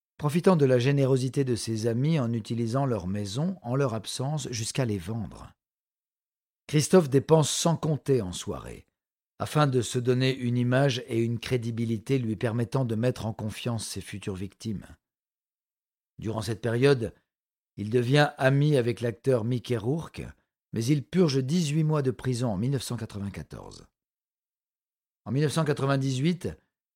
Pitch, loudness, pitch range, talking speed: 125 Hz, -27 LUFS, 115-140 Hz, 140 wpm